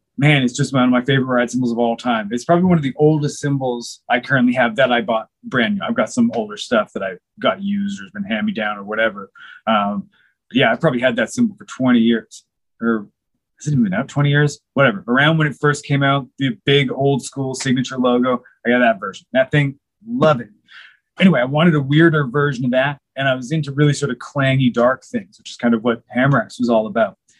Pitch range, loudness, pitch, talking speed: 125-155 Hz, -18 LUFS, 135 Hz, 245 wpm